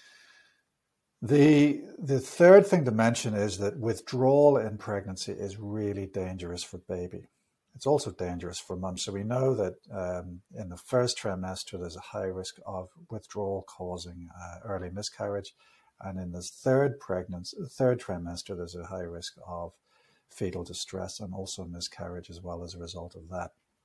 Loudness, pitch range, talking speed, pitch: -29 LUFS, 90-115 Hz, 160 wpm, 95 Hz